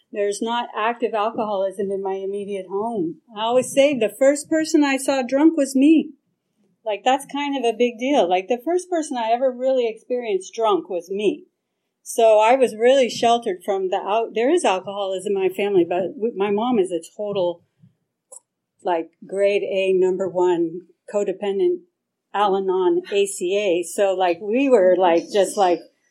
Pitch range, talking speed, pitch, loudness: 190-255 Hz, 170 wpm, 210 Hz, -20 LUFS